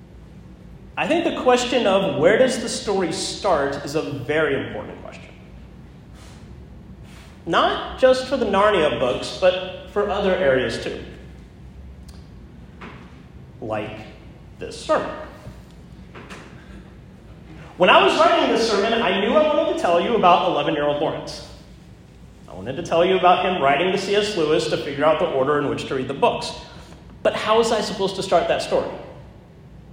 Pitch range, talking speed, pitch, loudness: 145-230 Hz, 150 wpm, 185 Hz, -20 LUFS